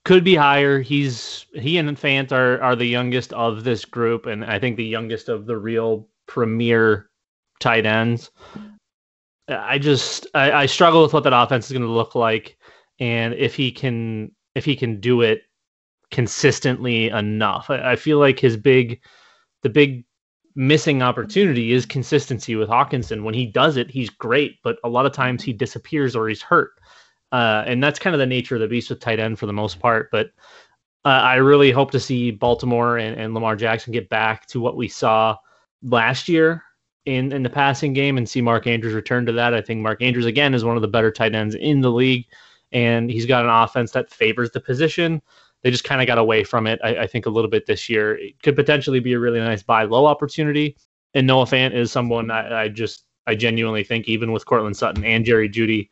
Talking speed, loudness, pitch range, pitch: 210 wpm, -19 LUFS, 115-135 Hz, 120 Hz